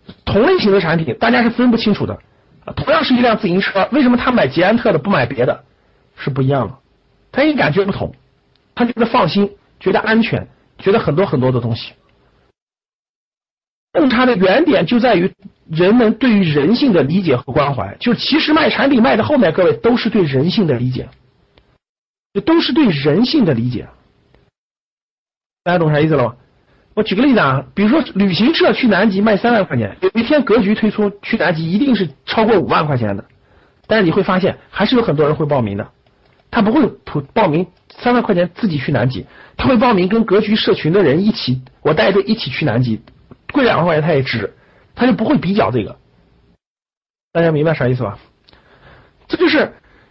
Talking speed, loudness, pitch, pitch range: 290 characters per minute, -15 LUFS, 195 Hz, 140-230 Hz